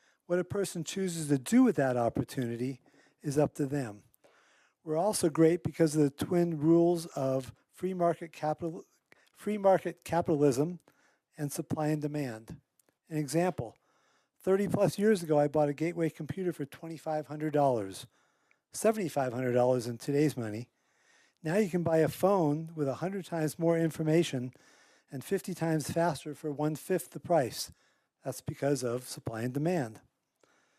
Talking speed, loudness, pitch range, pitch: 145 wpm, -31 LUFS, 140-170 Hz, 155 Hz